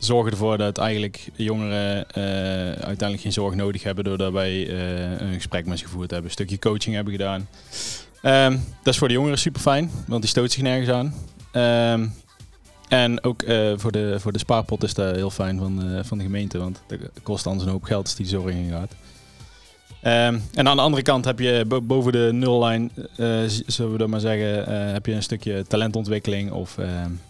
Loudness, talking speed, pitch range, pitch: -23 LUFS, 205 wpm, 95-120 Hz, 105 Hz